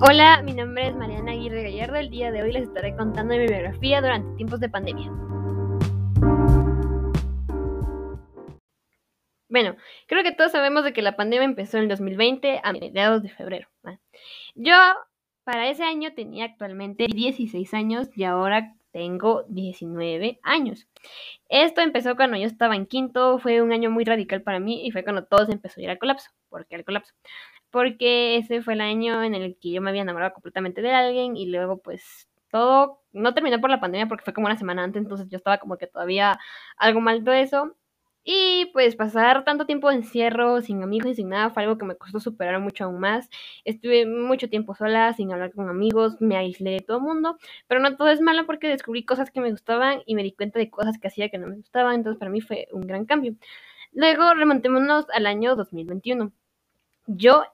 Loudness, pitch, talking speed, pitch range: -22 LUFS, 225 Hz, 195 wpm, 195-255 Hz